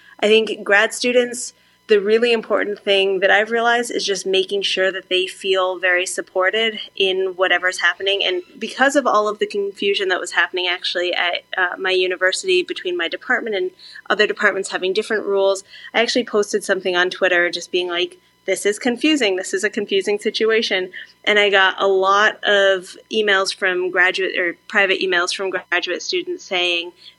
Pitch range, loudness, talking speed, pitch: 185-220 Hz, -18 LUFS, 175 wpm, 195 Hz